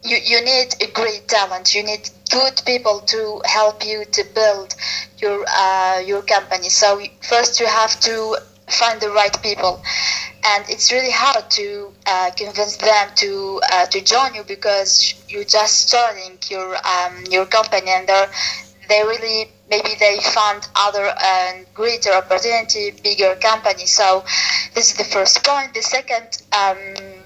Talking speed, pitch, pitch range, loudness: 155 wpm, 210 Hz, 195-225 Hz, -16 LUFS